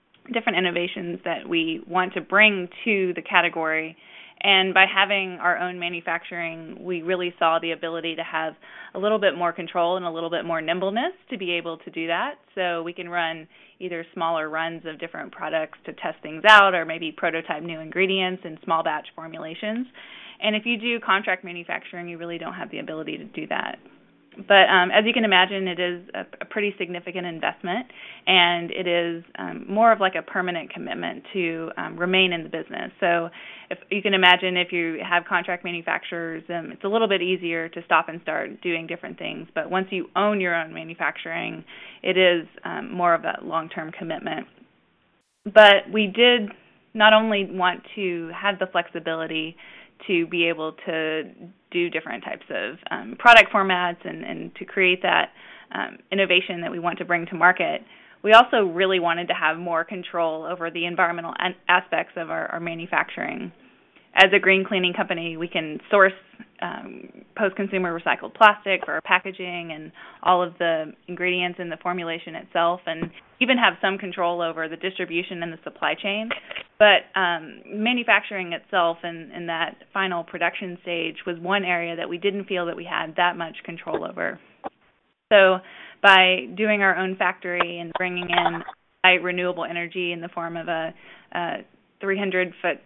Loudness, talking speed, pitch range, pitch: -22 LUFS, 180 wpm, 170-195 Hz, 180 Hz